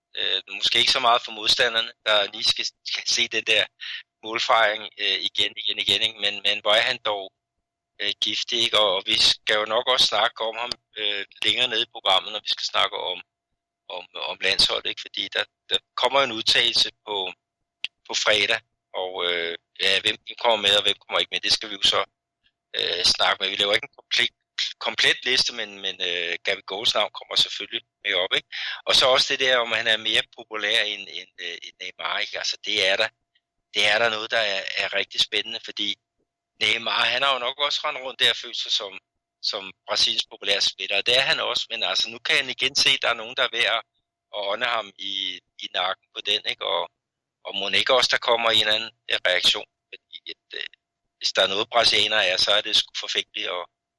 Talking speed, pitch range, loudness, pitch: 215 wpm, 100-115 Hz, -22 LUFS, 110 Hz